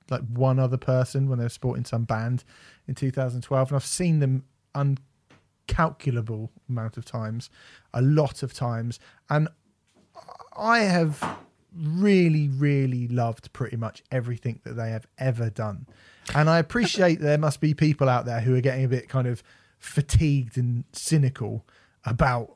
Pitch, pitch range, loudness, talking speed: 130 Hz, 120-145 Hz, -25 LUFS, 150 wpm